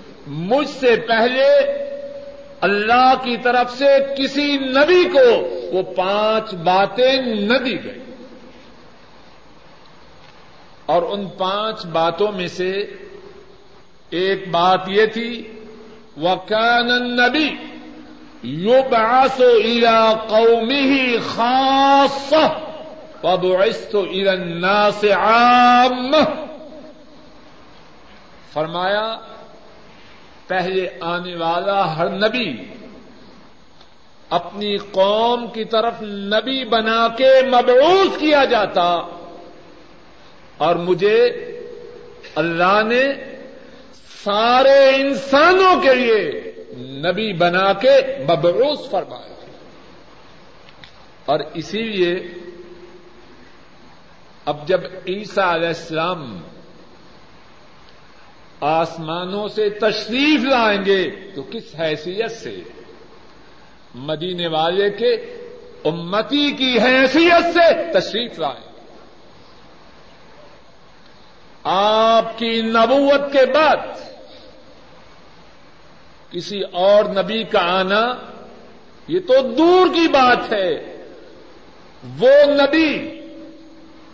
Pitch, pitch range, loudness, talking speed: 230 Hz, 195-280 Hz, -16 LUFS, 80 wpm